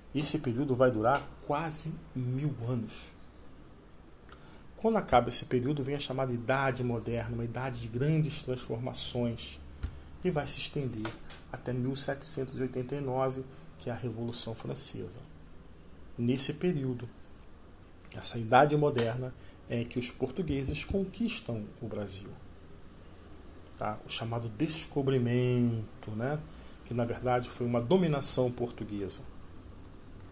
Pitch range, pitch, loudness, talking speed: 105-140 Hz, 125 Hz, -32 LUFS, 110 wpm